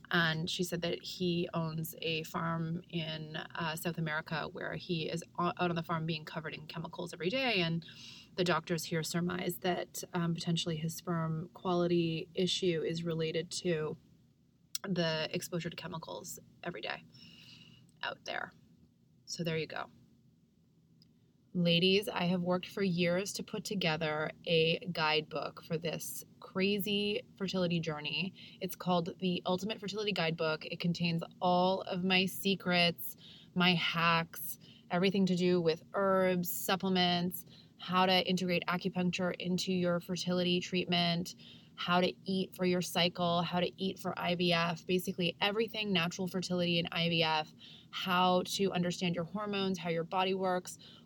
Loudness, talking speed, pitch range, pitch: -34 LUFS, 145 wpm, 165-185 Hz, 175 Hz